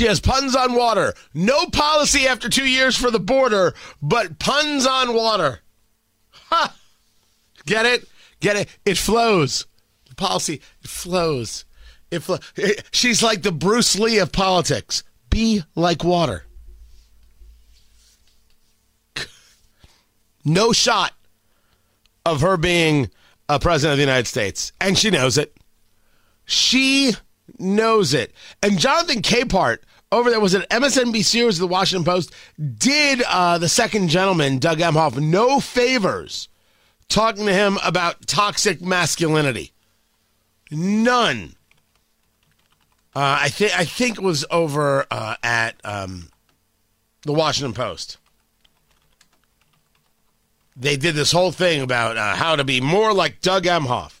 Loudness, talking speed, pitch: -18 LUFS, 130 wpm, 170 Hz